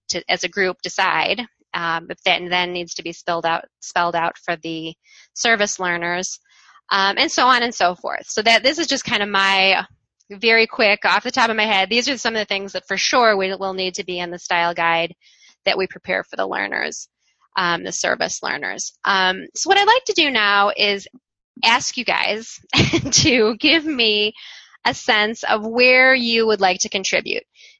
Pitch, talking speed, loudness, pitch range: 200 Hz, 205 wpm, -18 LUFS, 180-235 Hz